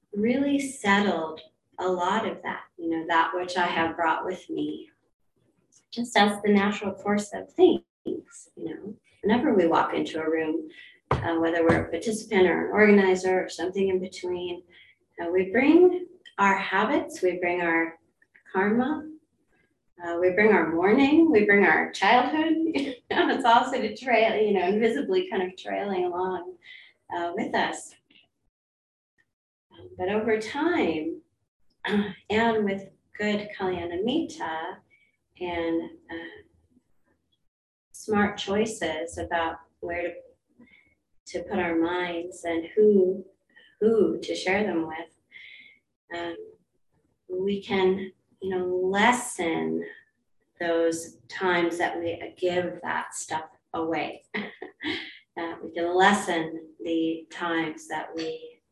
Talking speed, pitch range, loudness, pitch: 125 wpm, 170-240 Hz, -25 LUFS, 190 Hz